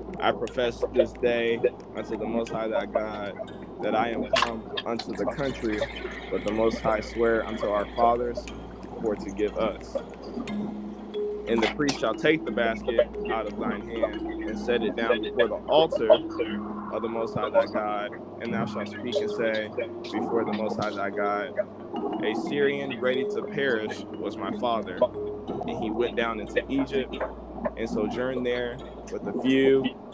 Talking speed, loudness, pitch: 170 wpm, -28 LUFS, 115 Hz